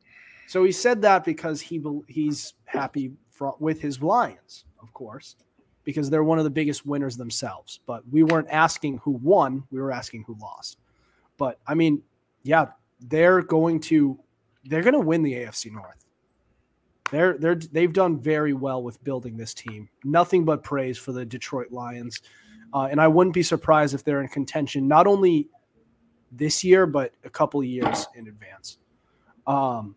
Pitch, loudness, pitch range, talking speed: 145 Hz, -23 LUFS, 125-160 Hz, 170 wpm